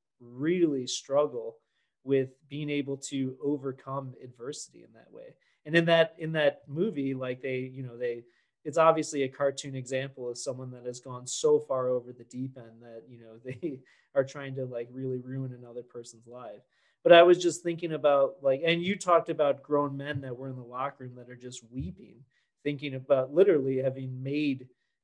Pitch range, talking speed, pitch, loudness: 125-150 Hz, 190 wpm, 135 Hz, -29 LUFS